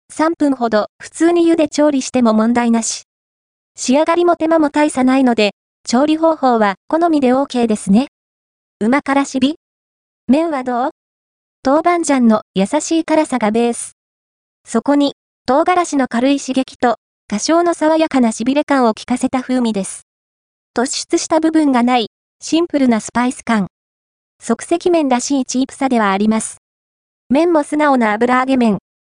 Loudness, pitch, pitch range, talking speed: -15 LUFS, 255 Hz, 225-300 Hz, 290 characters per minute